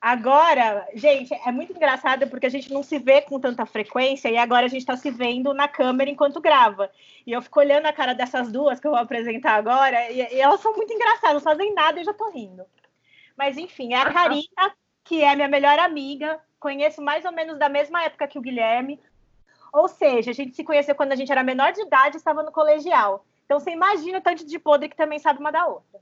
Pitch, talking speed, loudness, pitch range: 285 Hz, 235 wpm, -21 LUFS, 255-310 Hz